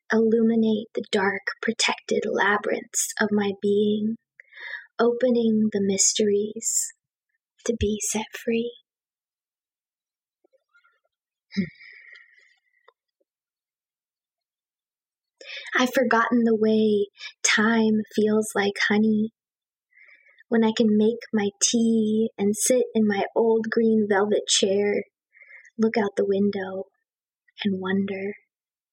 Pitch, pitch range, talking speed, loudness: 220 Hz, 205-235 Hz, 90 wpm, -23 LUFS